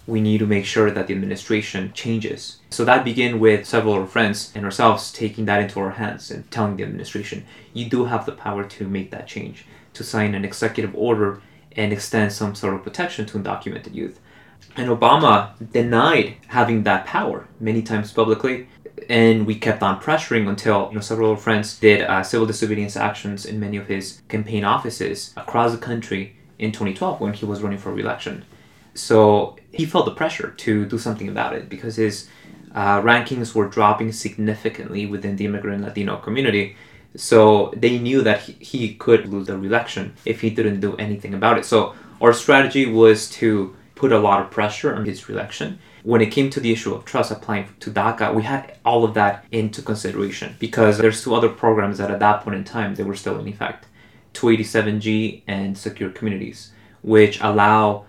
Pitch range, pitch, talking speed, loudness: 100-115 Hz, 110 Hz, 190 wpm, -20 LUFS